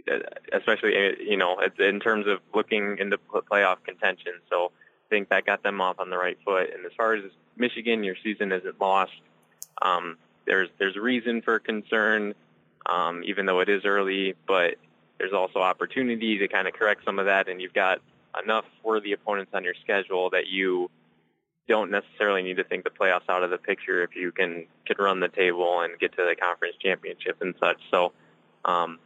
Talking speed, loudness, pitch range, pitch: 190 wpm, -26 LUFS, 90-110 Hz, 100 Hz